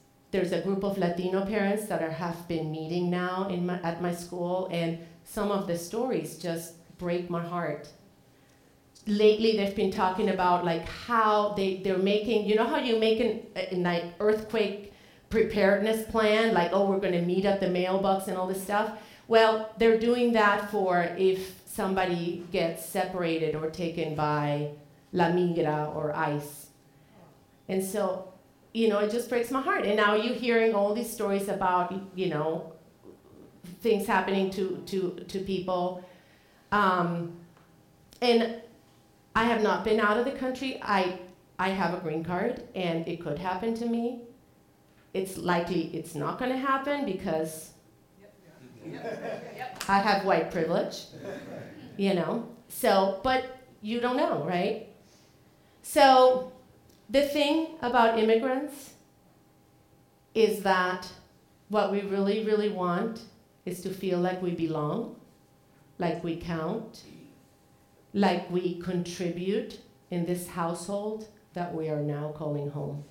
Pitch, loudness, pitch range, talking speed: 190 Hz, -28 LUFS, 175-215 Hz, 145 wpm